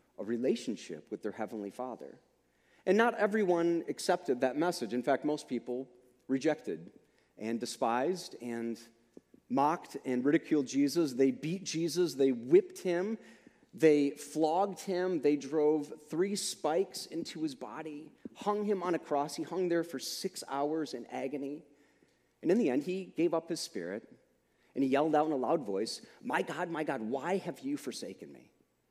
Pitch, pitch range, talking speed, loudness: 155 Hz, 135-180 Hz, 165 wpm, -33 LUFS